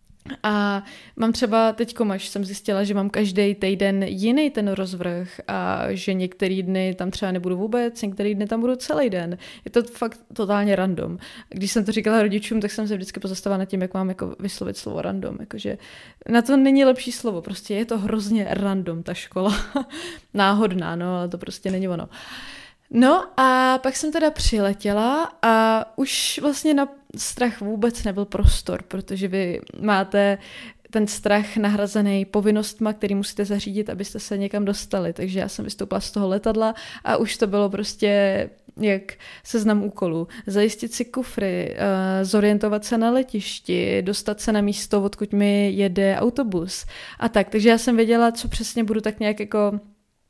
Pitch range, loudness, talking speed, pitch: 195-230 Hz, -22 LUFS, 170 wpm, 210 Hz